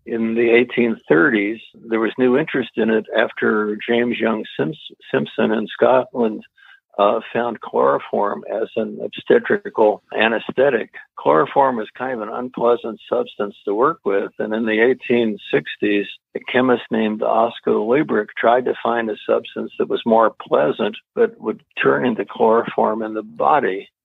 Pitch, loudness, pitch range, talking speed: 115 Hz, -19 LUFS, 110-125 Hz, 145 wpm